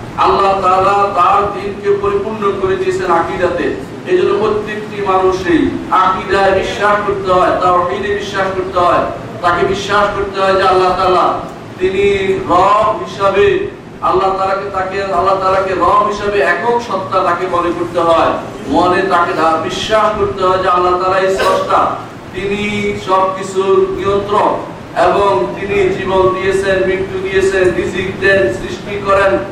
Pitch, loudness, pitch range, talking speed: 190 Hz, -13 LUFS, 185-200 Hz, 130 wpm